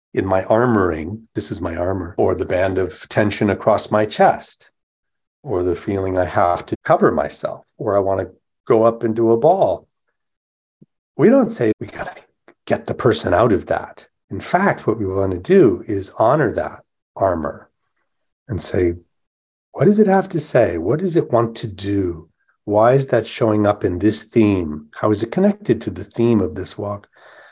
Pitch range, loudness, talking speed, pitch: 90-115 Hz, -18 LUFS, 190 wpm, 105 Hz